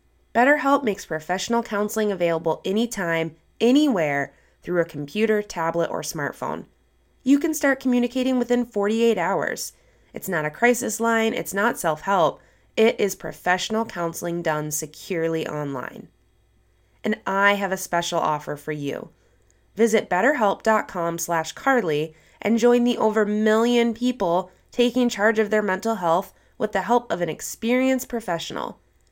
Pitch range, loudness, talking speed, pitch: 165-235 Hz, -23 LUFS, 130 wpm, 205 Hz